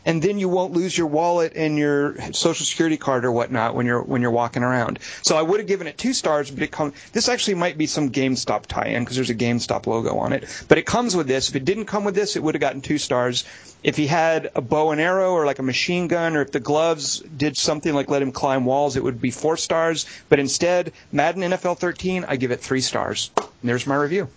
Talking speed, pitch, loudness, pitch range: 250 wpm, 150 Hz, -21 LUFS, 130-175 Hz